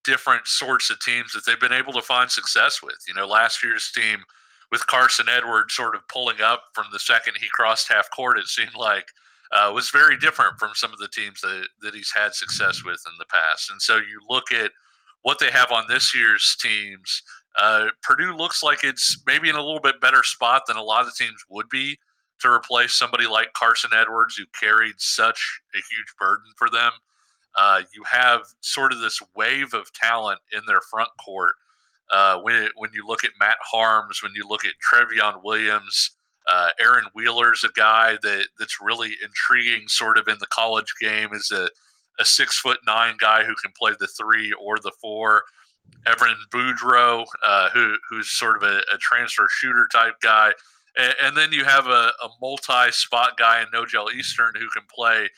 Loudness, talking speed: -19 LUFS, 200 wpm